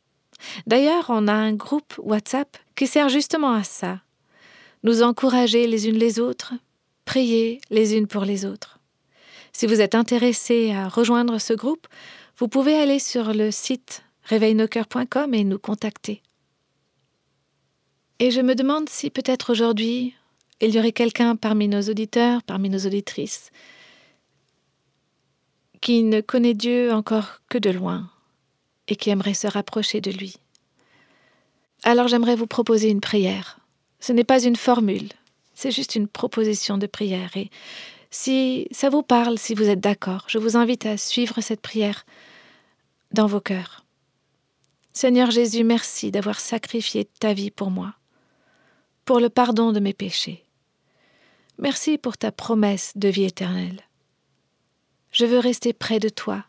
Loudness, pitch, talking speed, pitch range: -21 LUFS, 225 Hz, 145 wpm, 205-245 Hz